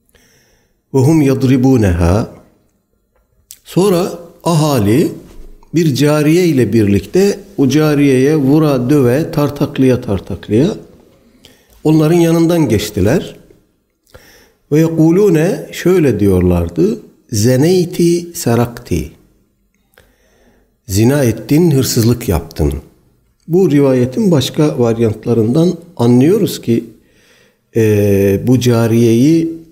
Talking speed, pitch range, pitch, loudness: 75 wpm, 110-160 Hz, 135 Hz, -12 LUFS